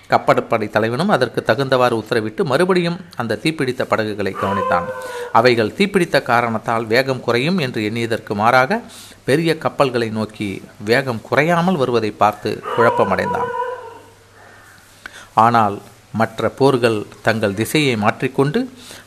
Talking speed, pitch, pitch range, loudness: 100 wpm, 125 Hz, 110-170 Hz, -18 LUFS